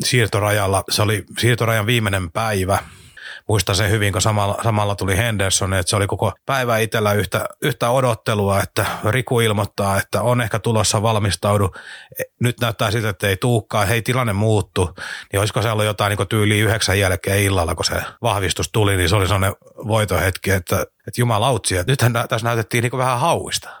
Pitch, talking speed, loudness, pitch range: 105 Hz, 175 wpm, -19 LUFS, 100-115 Hz